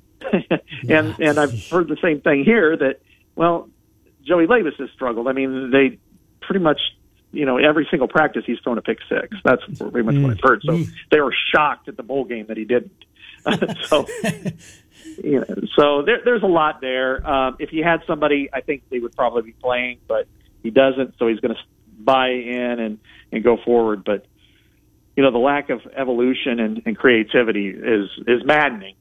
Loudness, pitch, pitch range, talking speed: -19 LUFS, 130 Hz, 115-150 Hz, 190 wpm